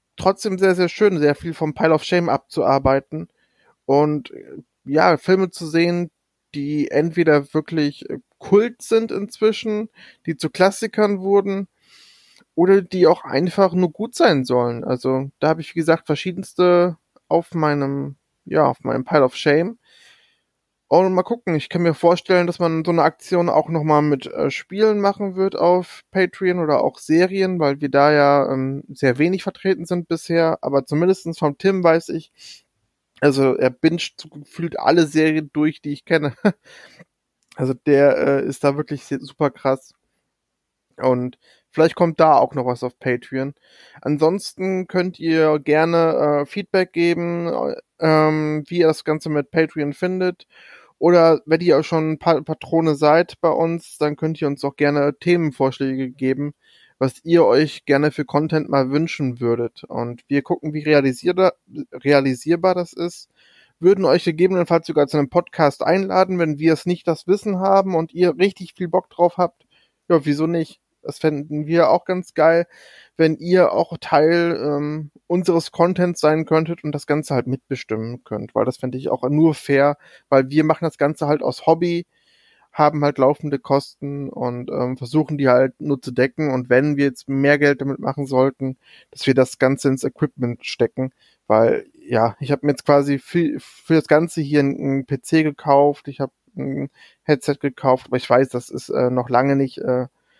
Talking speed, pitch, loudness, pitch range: 170 wpm, 155 Hz, -19 LUFS, 140-175 Hz